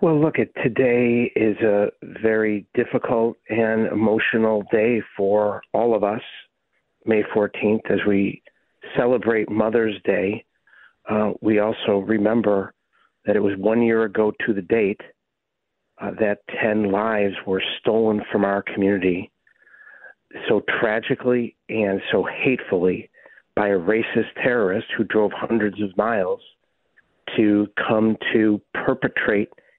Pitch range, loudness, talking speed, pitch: 100-110 Hz, -21 LUFS, 125 wpm, 105 Hz